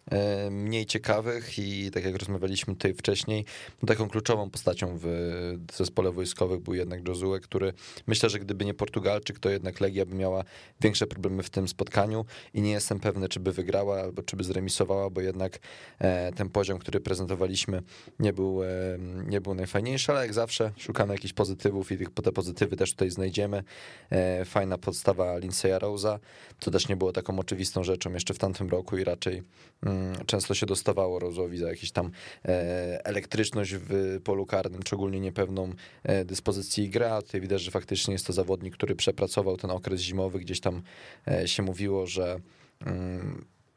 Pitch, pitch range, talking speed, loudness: 95 Hz, 95-105 Hz, 160 wpm, -30 LUFS